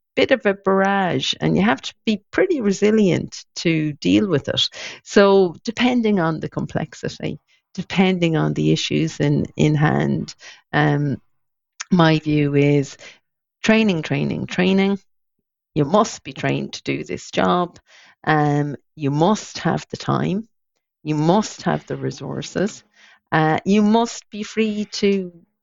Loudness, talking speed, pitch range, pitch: -20 LUFS, 140 wpm, 150-210 Hz, 180 Hz